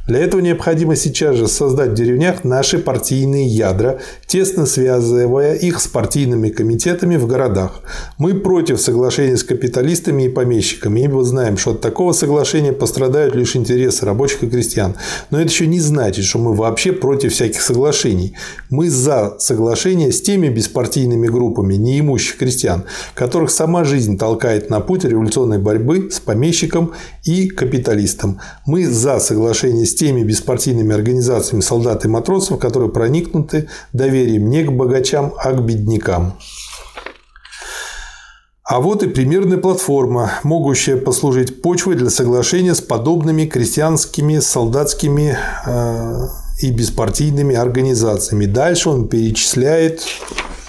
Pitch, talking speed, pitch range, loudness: 130 Hz, 130 wpm, 115-160 Hz, -15 LUFS